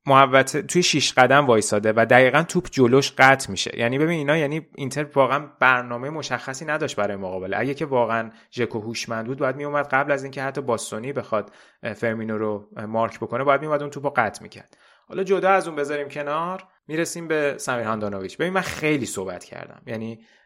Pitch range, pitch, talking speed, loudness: 115-150 Hz, 135 Hz, 185 wpm, -22 LUFS